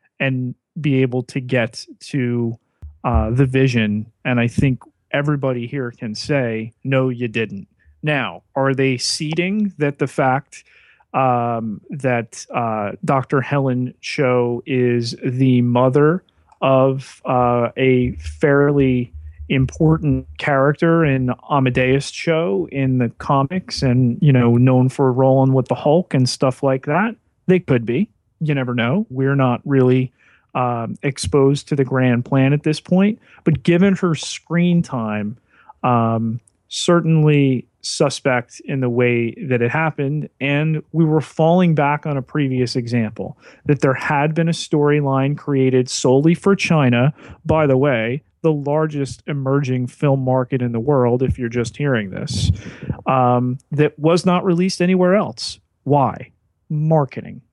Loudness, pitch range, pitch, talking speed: -18 LUFS, 125-150 Hz, 135 Hz, 140 wpm